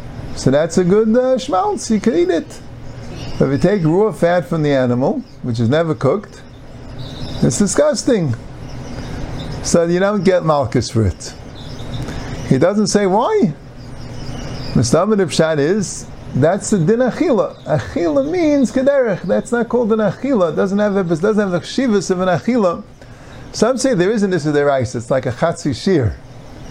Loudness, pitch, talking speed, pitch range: -16 LUFS, 160 Hz, 170 wpm, 130-210 Hz